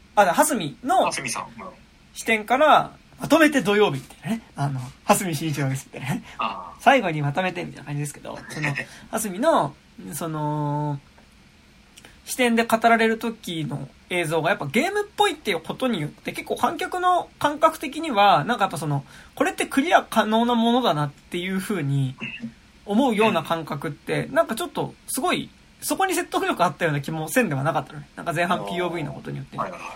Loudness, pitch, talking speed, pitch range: -23 LUFS, 190 Hz, 365 characters per minute, 150-250 Hz